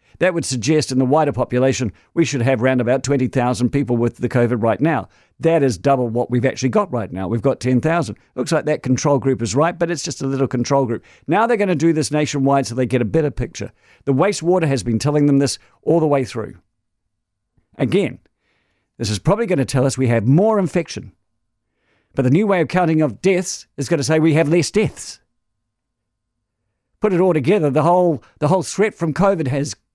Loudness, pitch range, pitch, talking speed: -18 LUFS, 120-160 Hz, 135 Hz, 220 wpm